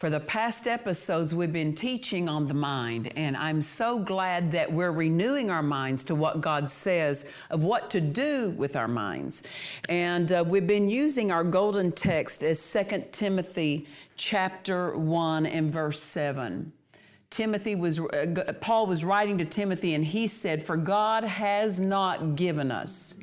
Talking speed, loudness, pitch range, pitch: 165 wpm, -27 LUFS, 155-200 Hz, 175 Hz